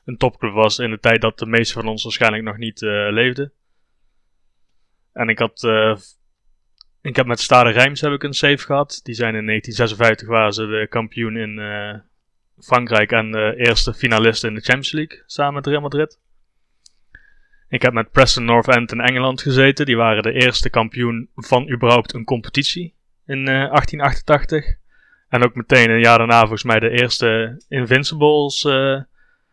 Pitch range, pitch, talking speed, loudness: 115-140 Hz, 120 Hz, 170 wpm, -16 LUFS